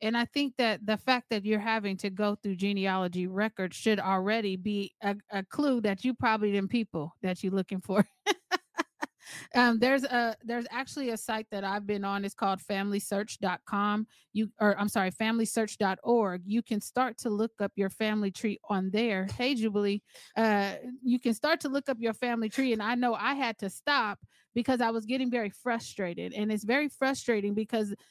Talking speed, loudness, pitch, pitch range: 190 wpm, -30 LUFS, 220 Hz, 200-240 Hz